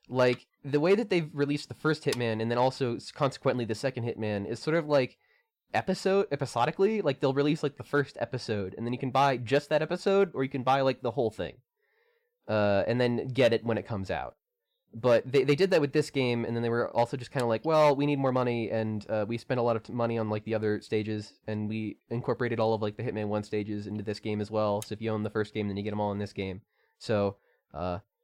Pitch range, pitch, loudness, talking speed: 110-145 Hz, 120 Hz, -29 LUFS, 260 wpm